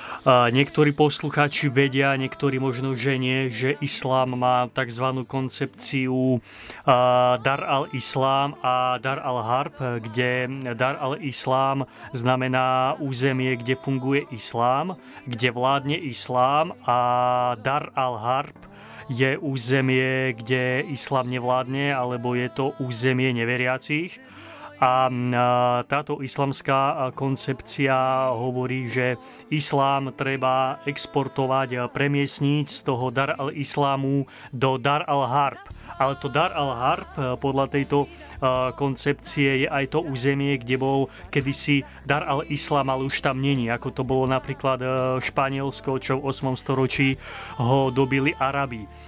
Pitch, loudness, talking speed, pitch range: 130 Hz, -23 LUFS, 115 wpm, 125-140 Hz